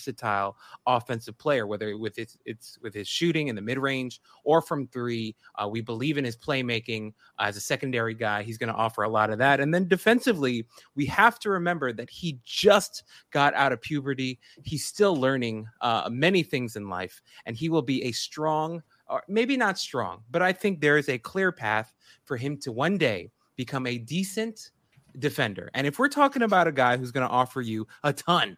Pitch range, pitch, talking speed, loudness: 115-165 Hz, 135 Hz, 205 wpm, -26 LUFS